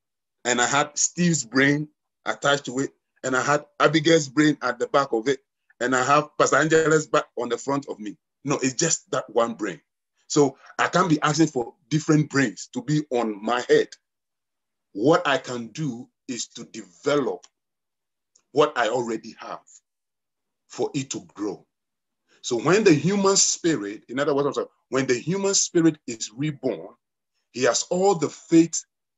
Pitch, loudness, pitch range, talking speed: 145 Hz, -23 LUFS, 125-160 Hz, 165 wpm